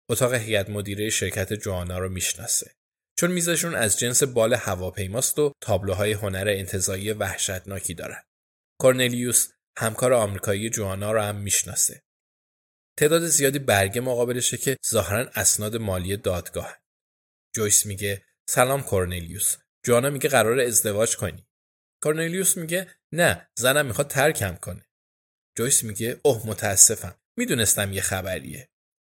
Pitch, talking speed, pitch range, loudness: 105 Hz, 120 wpm, 95-125 Hz, -23 LUFS